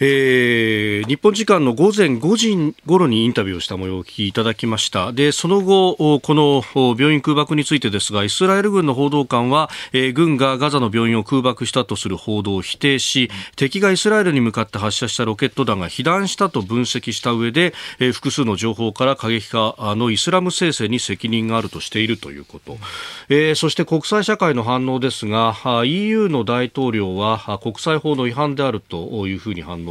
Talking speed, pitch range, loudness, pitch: 385 characters per minute, 110-150 Hz, -18 LUFS, 125 Hz